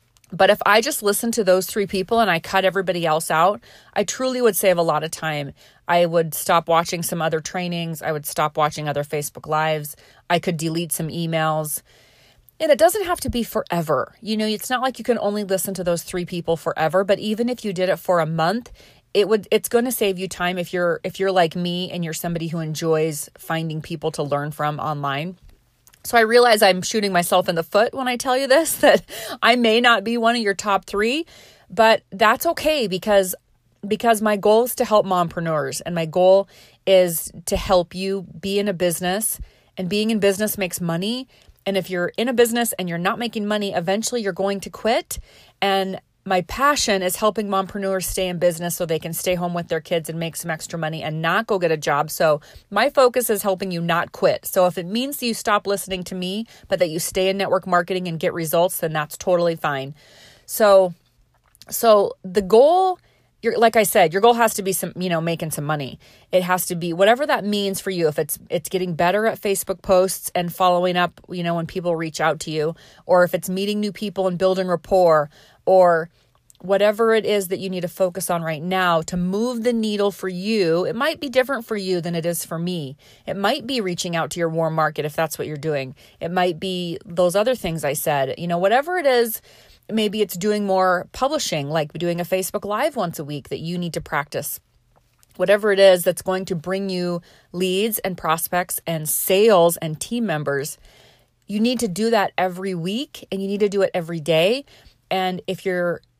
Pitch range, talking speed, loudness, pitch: 165-210 Hz, 220 wpm, -20 LUFS, 185 Hz